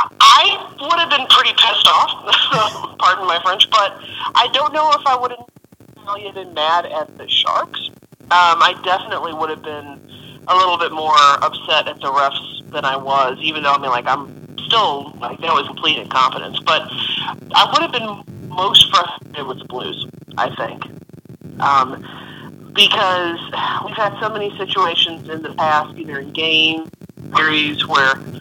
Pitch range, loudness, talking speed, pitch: 150-200 Hz, -15 LUFS, 170 wpm, 160 Hz